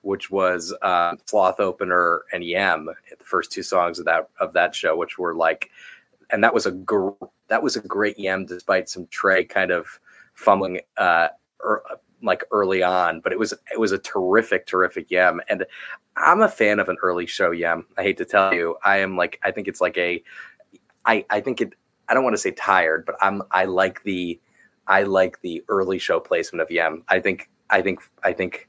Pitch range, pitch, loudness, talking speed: 90-100 Hz, 95 Hz, -21 LUFS, 210 wpm